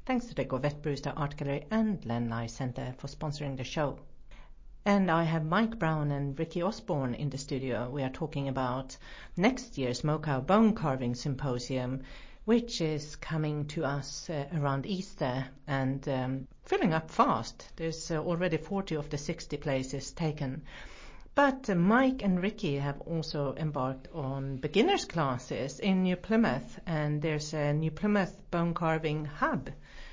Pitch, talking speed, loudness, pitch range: 150 Hz, 155 wpm, -32 LUFS, 135-180 Hz